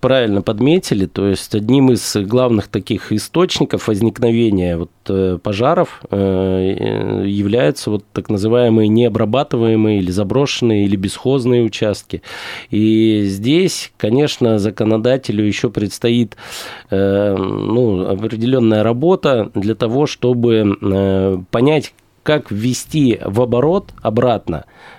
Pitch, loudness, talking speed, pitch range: 110 Hz, -15 LUFS, 95 wpm, 100-125 Hz